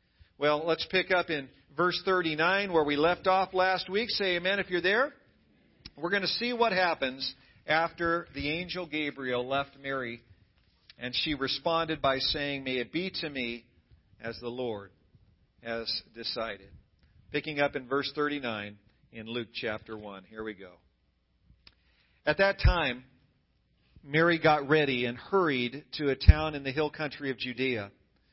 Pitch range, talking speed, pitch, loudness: 115-165 Hz, 155 wpm, 135 Hz, -29 LUFS